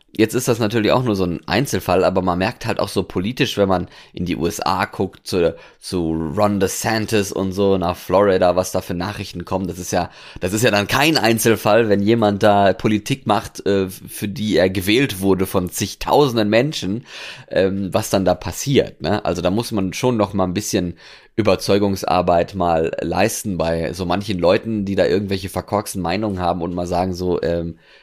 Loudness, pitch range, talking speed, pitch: -19 LUFS, 90-105 Hz, 190 wpm, 100 Hz